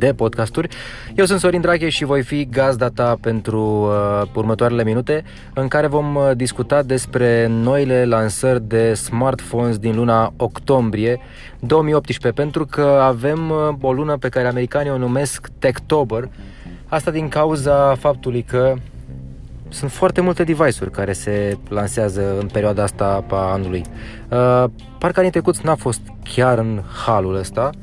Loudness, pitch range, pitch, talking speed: -18 LUFS, 110-145 Hz, 125 Hz, 145 wpm